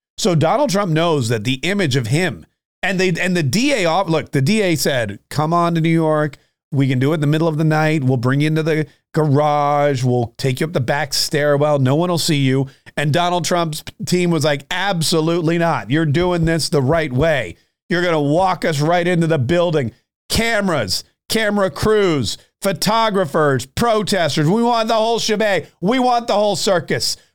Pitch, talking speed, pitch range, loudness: 160 Hz, 195 wpm, 145-180 Hz, -17 LUFS